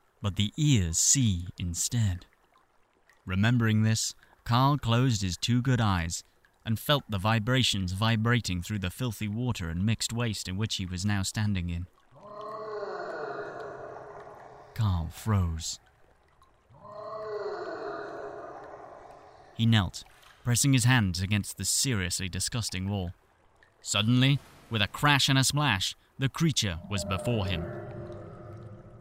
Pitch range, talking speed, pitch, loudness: 95-130 Hz, 115 wpm, 110 Hz, -28 LUFS